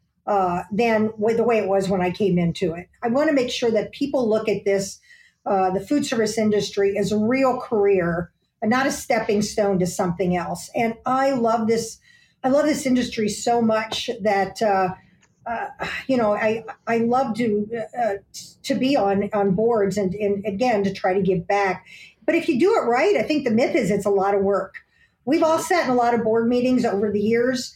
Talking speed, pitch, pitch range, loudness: 215 wpm, 220 Hz, 200-250 Hz, -21 LUFS